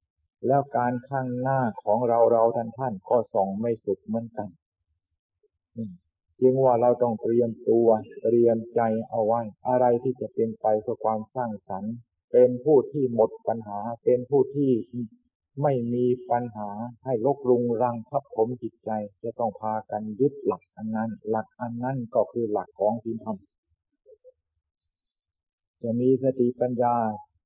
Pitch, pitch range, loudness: 115 Hz, 110-125 Hz, -25 LUFS